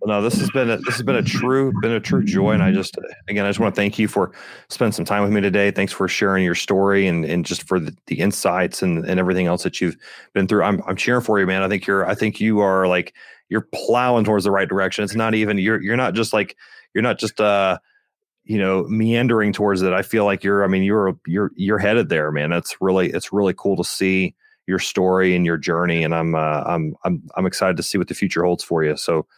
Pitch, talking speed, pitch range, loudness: 100 Hz, 260 wpm, 95-110 Hz, -19 LUFS